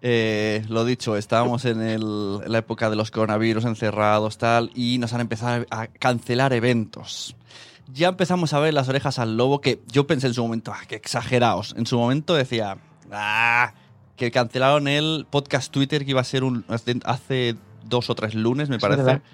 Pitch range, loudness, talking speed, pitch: 115-130 Hz, -22 LUFS, 185 wpm, 120 Hz